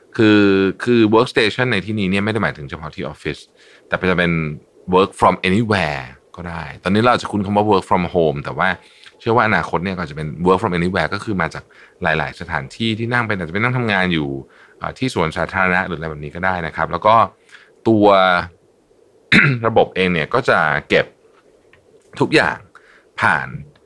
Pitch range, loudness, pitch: 85-115 Hz, -17 LUFS, 95 Hz